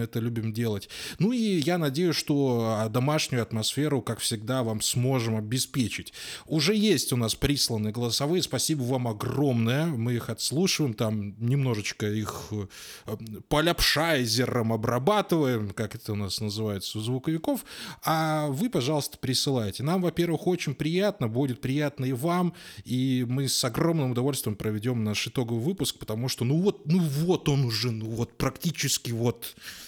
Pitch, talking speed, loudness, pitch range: 130 Hz, 145 wpm, -27 LUFS, 115-155 Hz